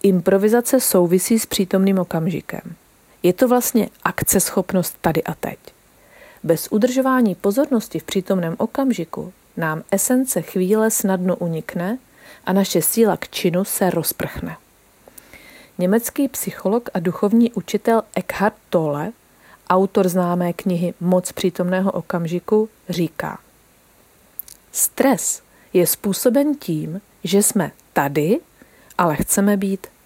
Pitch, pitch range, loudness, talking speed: 195 Hz, 180-220 Hz, -19 LUFS, 110 wpm